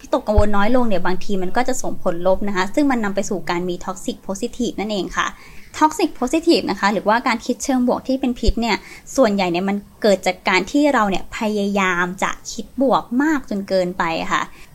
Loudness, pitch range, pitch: -20 LUFS, 190-255 Hz, 210 Hz